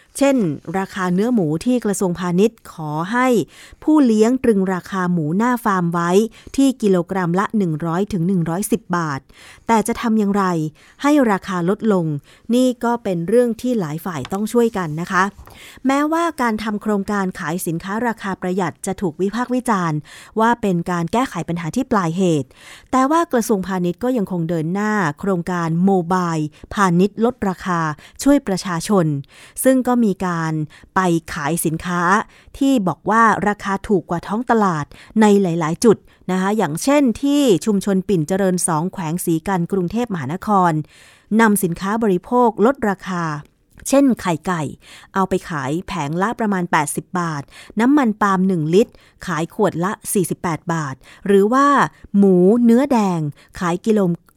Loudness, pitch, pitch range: -18 LUFS, 190 Hz, 175-225 Hz